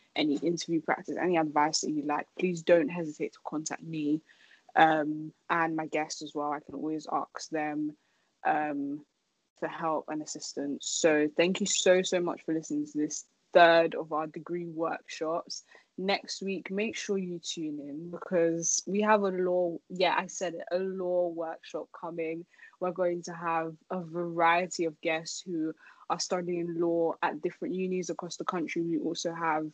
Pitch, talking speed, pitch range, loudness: 170 Hz, 175 wpm, 155-180 Hz, -30 LUFS